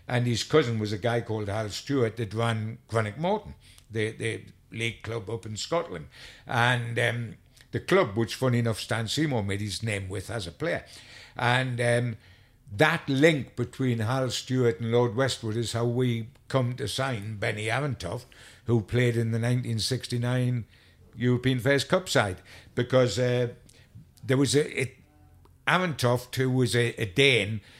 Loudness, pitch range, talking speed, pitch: -27 LUFS, 110-125 Hz, 160 wpm, 120 Hz